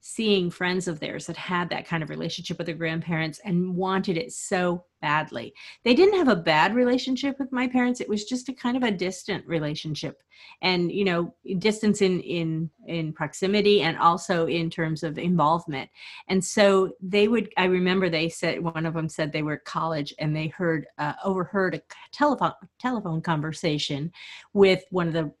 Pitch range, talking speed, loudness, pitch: 160-195 Hz, 185 wpm, -25 LUFS, 175 Hz